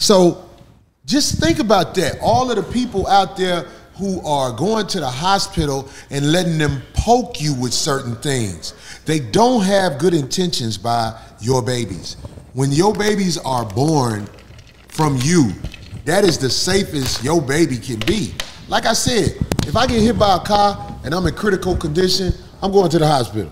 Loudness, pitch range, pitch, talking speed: -17 LUFS, 125-190 Hz, 155 Hz, 175 wpm